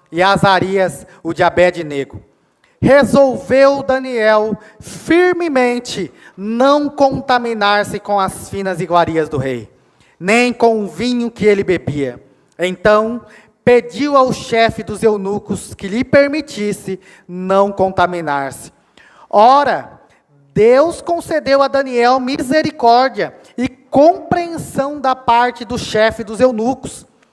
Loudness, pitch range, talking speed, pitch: -14 LUFS, 190-260 Hz, 105 wpm, 220 Hz